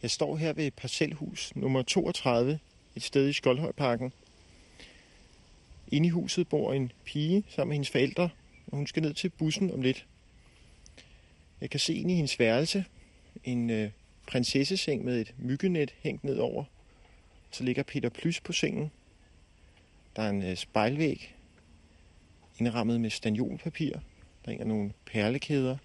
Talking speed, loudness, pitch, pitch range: 145 wpm, -31 LUFS, 130 Hz, 105-155 Hz